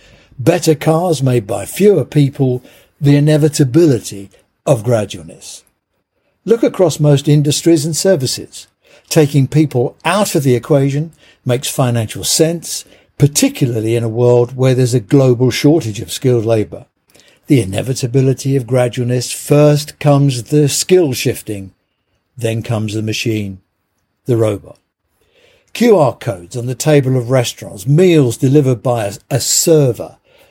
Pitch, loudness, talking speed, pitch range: 130 Hz, -13 LUFS, 125 wpm, 115-150 Hz